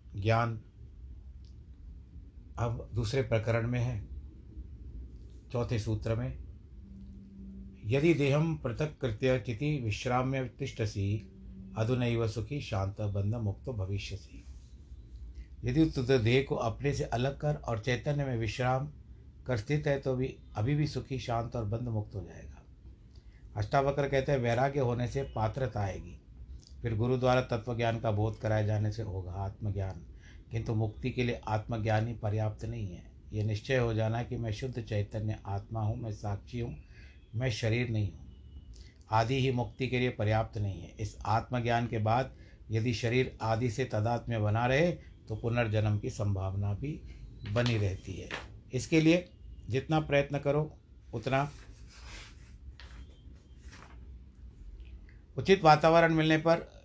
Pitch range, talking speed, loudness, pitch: 95-130 Hz, 140 wpm, -32 LUFS, 110 Hz